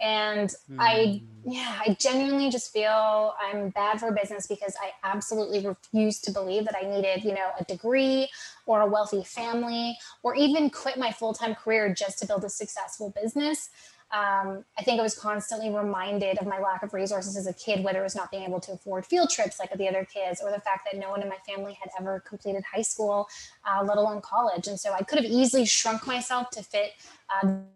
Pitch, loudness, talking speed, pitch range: 205 Hz, -28 LUFS, 215 wpm, 195-225 Hz